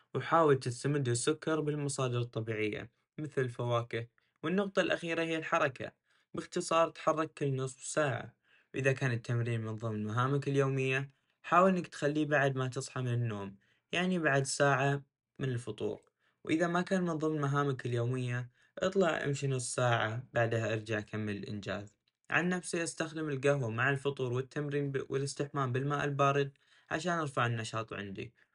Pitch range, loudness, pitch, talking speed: 120-155 Hz, -33 LUFS, 140 Hz, 135 wpm